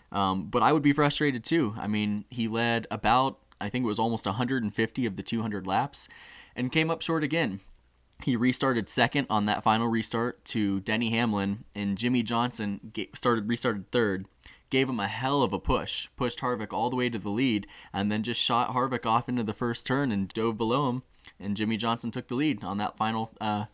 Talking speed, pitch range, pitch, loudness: 205 wpm, 105-125 Hz, 115 Hz, -28 LUFS